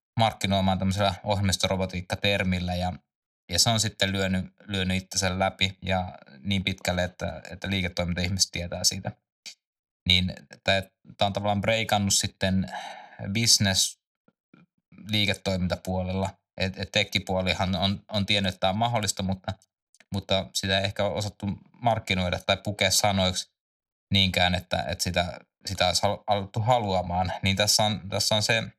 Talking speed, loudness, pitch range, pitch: 130 wpm, -26 LUFS, 95-100 Hz, 95 Hz